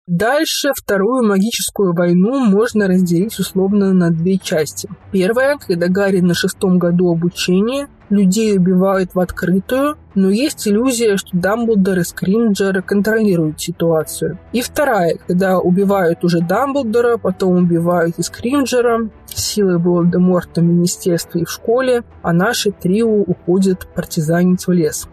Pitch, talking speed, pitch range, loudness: 190 Hz, 130 wpm, 175-215 Hz, -15 LUFS